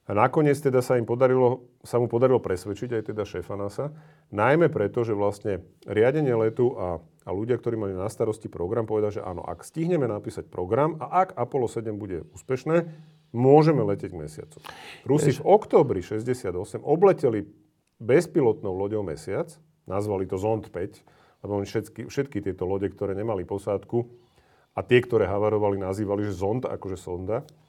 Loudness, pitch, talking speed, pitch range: -25 LUFS, 115 Hz, 160 wpm, 100-130 Hz